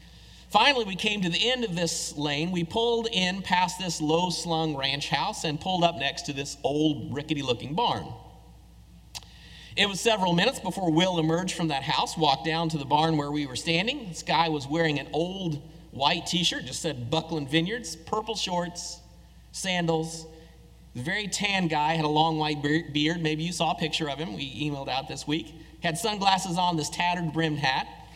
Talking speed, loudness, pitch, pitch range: 195 wpm, -27 LUFS, 165 Hz, 150-180 Hz